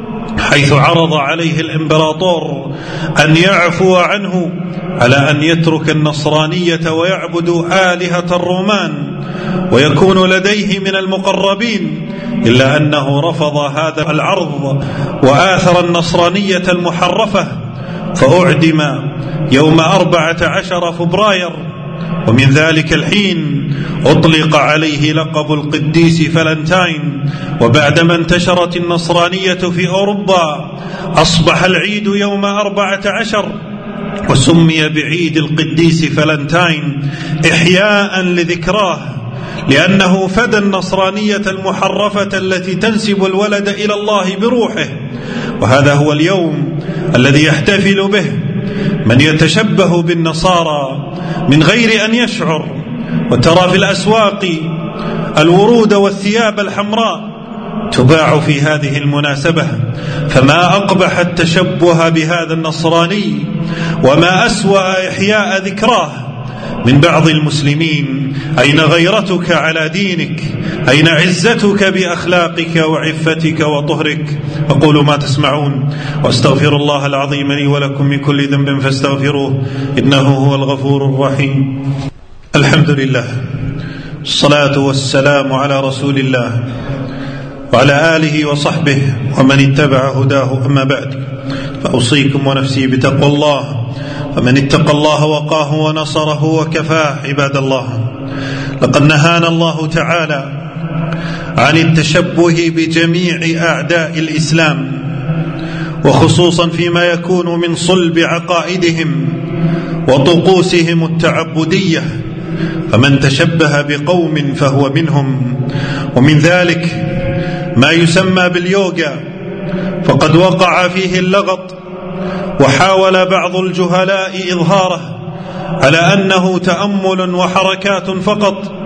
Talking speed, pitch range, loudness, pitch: 90 wpm, 145-185 Hz, -11 LUFS, 165 Hz